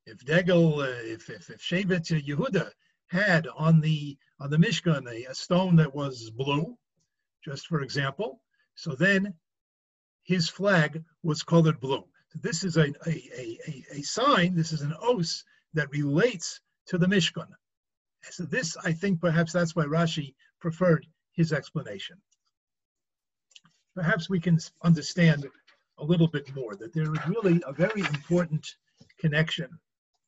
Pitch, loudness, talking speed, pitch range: 165 Hz, -27 LUFS, 145 wpm, 150-180 Hz